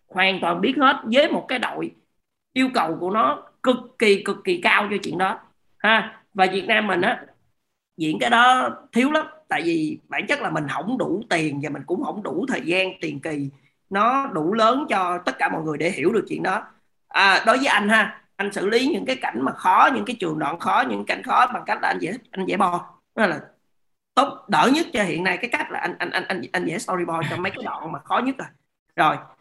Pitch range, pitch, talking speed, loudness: 180-260 Hz, 215 Hz, 240 wpm, -21 LUFS